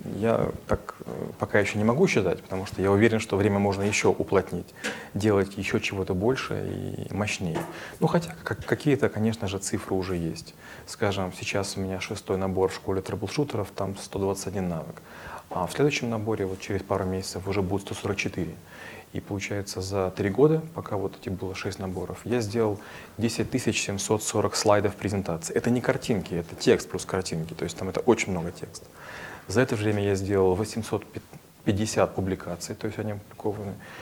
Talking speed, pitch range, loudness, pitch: 170 wpm, 95-110 Hz, -27 LUFS, 100 Hz